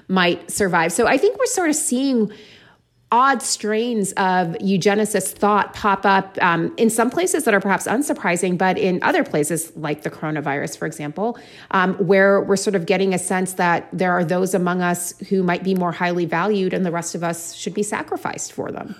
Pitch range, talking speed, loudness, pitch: 175-210 Hz, 200 wpm, -19 LUFS, 195 Hz